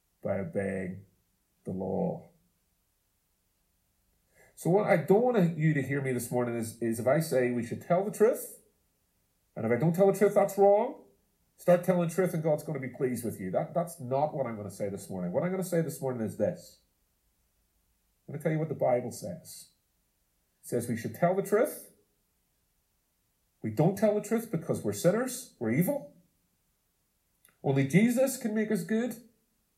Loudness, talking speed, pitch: -29 LUFS, 195 wpm, 140 Hz